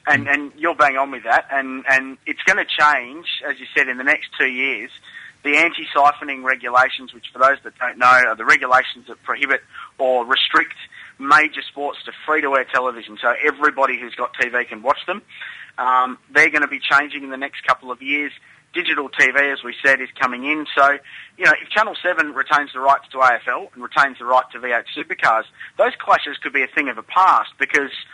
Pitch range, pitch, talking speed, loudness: 125-145 Hz, 135 Hz, 210 wpm, -18 LUFS